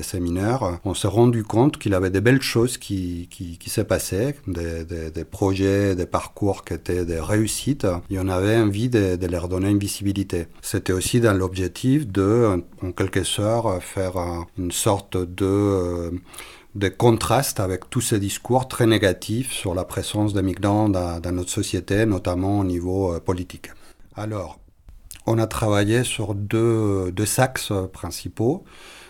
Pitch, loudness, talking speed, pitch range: 95 Hz, -22 LUFS, 160 wpm, 90-110 Hz